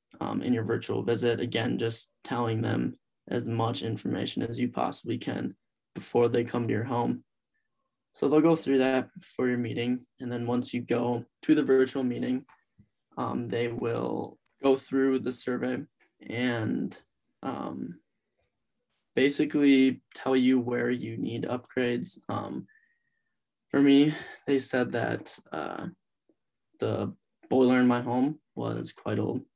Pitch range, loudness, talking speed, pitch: 120-135 Hz, -29 LUFS, 140 wpm, 125 Hz